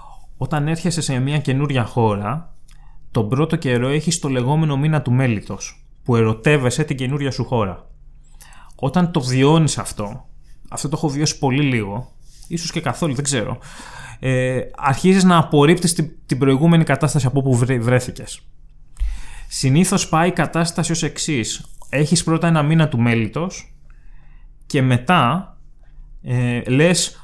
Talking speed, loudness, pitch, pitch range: 140 wpm, -18 LUFS, 140 Hz, 125-160 Hz